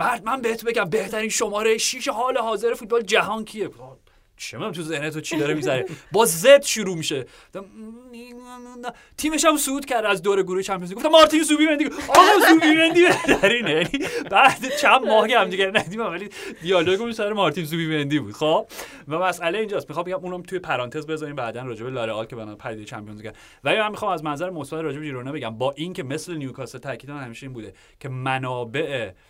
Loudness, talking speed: -20 LUFS, 195 wpm